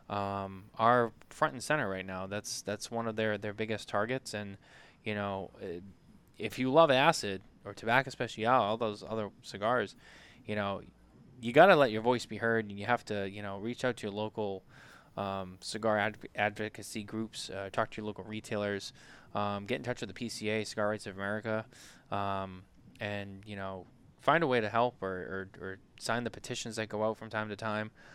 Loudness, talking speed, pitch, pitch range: -33 LUFS, 200 wpm, 105 Hz, 100-115 Hz